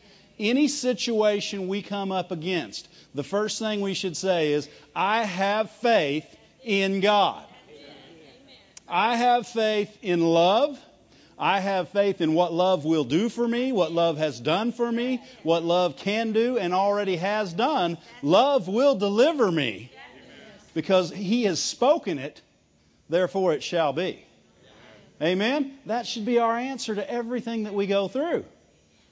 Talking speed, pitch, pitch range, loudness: 150 wpm, 205 Hz, 180-235 Hz, -24 LUFS